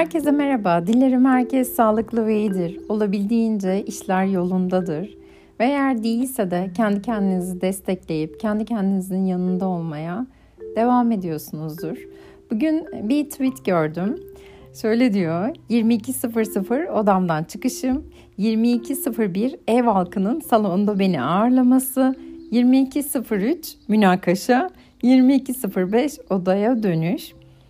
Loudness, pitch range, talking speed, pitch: -21 LUFS, 185-255 Hz, 95 wpm, 220 Hz